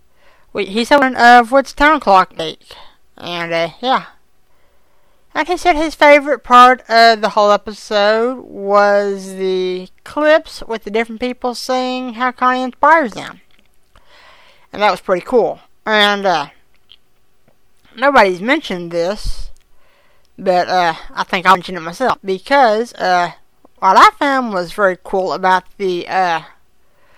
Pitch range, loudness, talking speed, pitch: 190-275 Hz, -14 LUFS, 135 wpm, 225 Hz